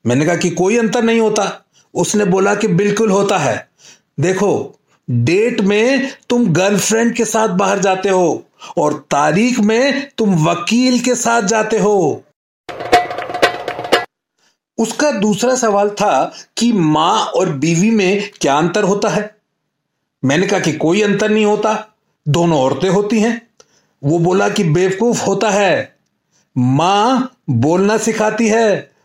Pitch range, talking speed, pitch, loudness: 185-225 Hz, 135 wpm, 205 Hz, -14 LUFS